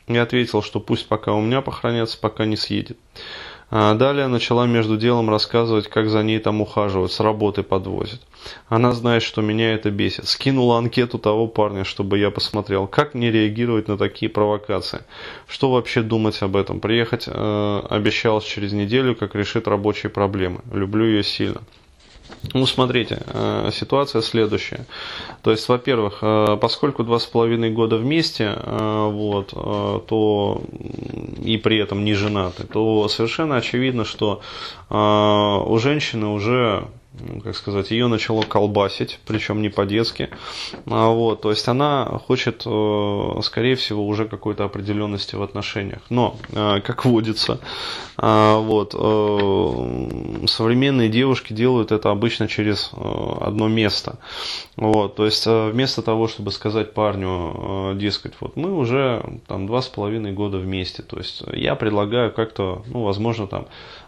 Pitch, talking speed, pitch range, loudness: 110 Hz, 135 wpm, 105-115 Hz, -20 LUFS